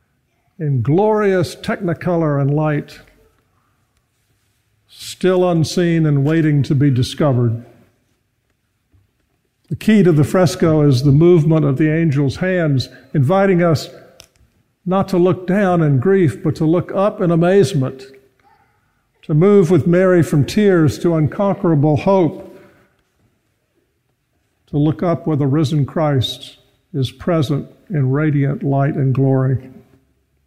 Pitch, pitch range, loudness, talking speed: 150 Hz, 130-175 Hz, -15 LUFS, 120 wpm